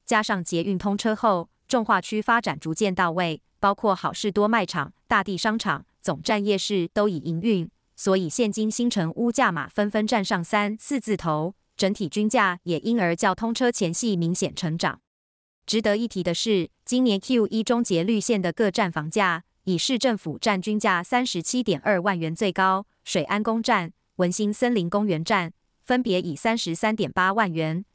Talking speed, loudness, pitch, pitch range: 270 characters per minute, -24 LUFS, 205 Hz, 180-225 Hz